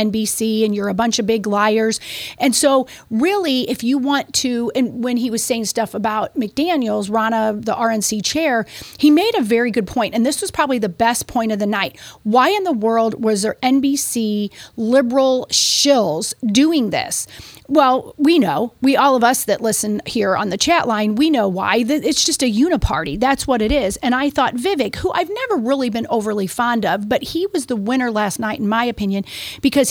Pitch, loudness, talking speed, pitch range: 240 Hz, -17 LUFS, 205 wpm, 220-275 Hz